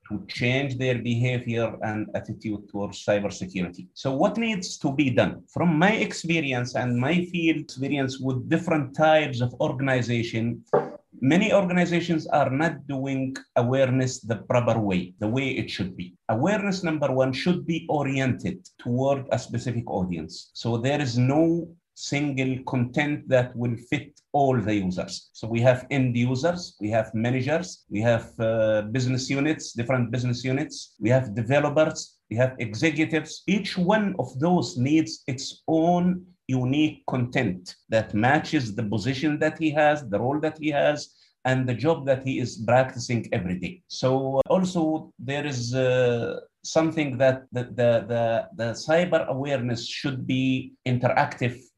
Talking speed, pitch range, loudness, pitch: 150 wpm, 120-155 Hz, -25 LUFS, 130 Hz